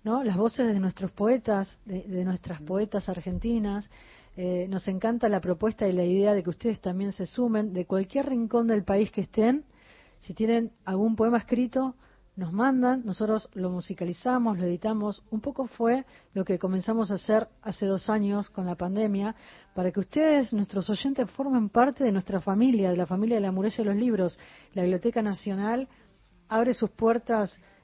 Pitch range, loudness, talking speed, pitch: 190-230 Hz, -27 LUFS, 180 wpm, 210 Hz